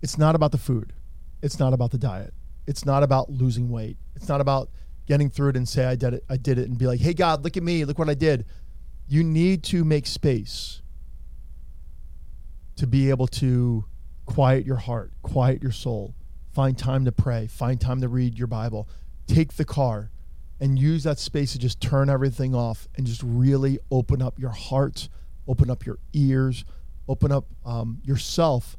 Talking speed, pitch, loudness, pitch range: 195 wpm, 130 Hz, -24 LUFS, 110-140 Hz